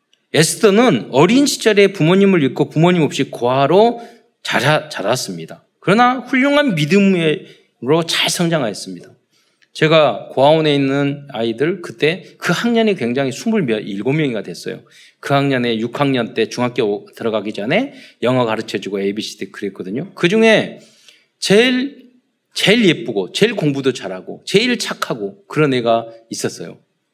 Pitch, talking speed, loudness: 155 Hz, 300 characters per minute, -16 LUFS